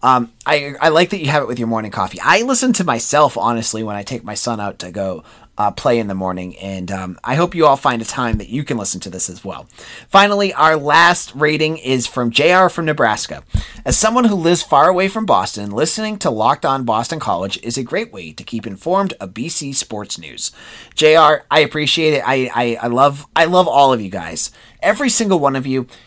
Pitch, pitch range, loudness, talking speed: 130 Hz, 115-160 Hz, -15 LUFS, 230 wpm